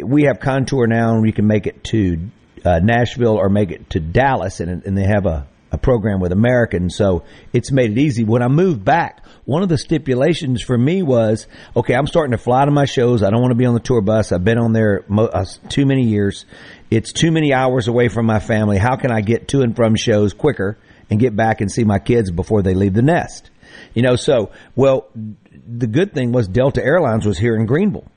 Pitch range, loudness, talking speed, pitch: 105-130 Hz, -16 LUFS, 235 wpm, 115 Hz